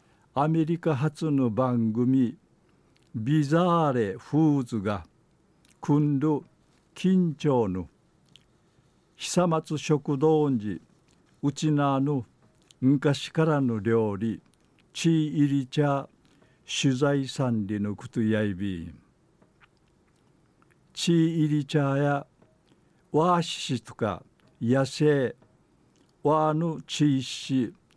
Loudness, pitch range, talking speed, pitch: -26 LUFS, 125-155 Hz, 165 characters per minute, 145 Hz